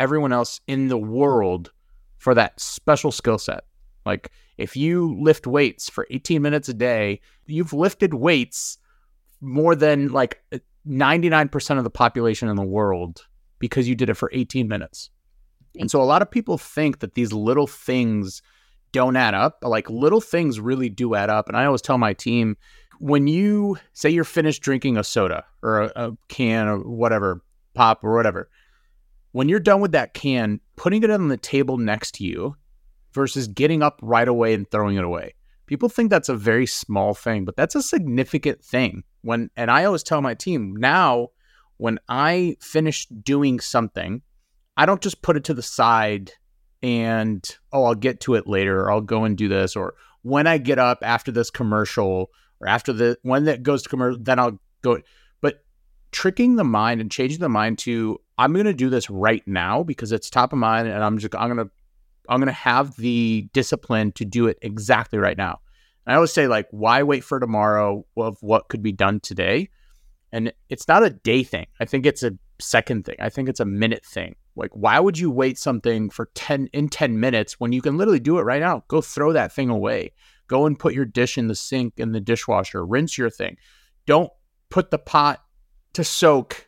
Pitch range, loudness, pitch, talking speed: 110-145 Hz, -21 LUFS, 120 Hz, 200 wpm